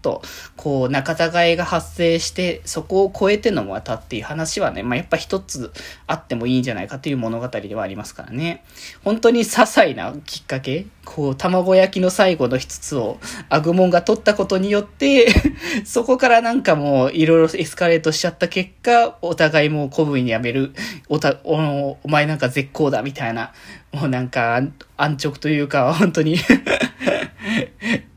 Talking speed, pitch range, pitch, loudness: 345 characters per minute, 140-195 Hz, 160 Hz, -19 LUFS